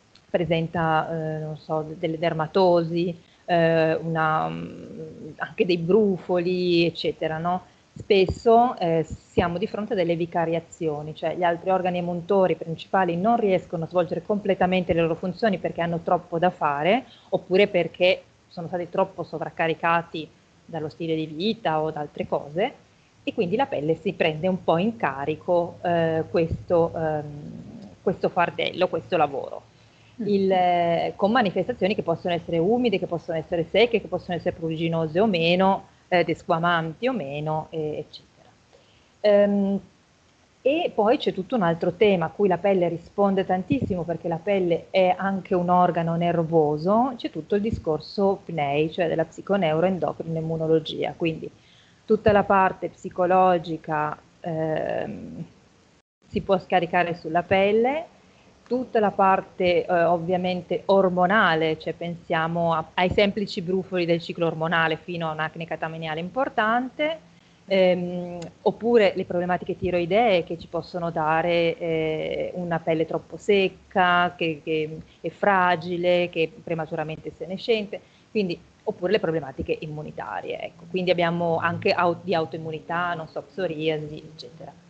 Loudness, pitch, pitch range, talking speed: -24 LUFS, 175 Hz, 165-190 Hz, 140 wpm